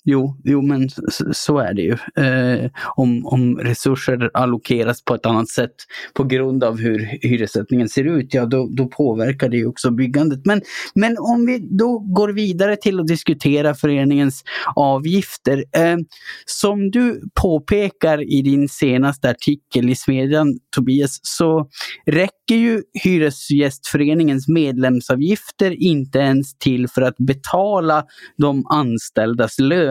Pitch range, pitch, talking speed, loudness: 130-165 Hz, 140 Hz, 135 wpm, -18 LUFS